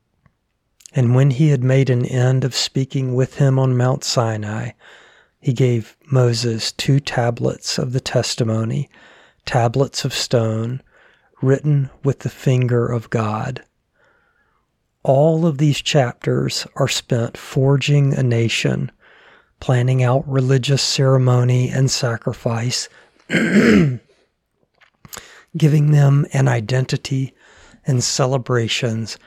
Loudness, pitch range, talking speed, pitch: -18 LUFS, 120-140 Hz, 105 wpm, 130 Hz